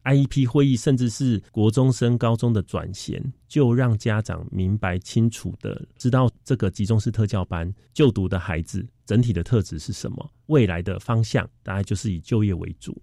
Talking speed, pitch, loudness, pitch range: 285 characters per minute, 115 Hz, -23 LUFS, 95-125 Hz